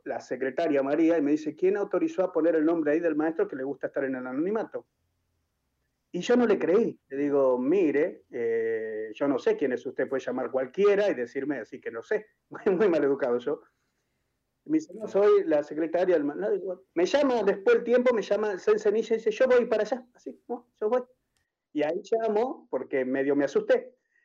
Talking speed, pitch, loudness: 220 wpm, 200 Hz, -27 LUFS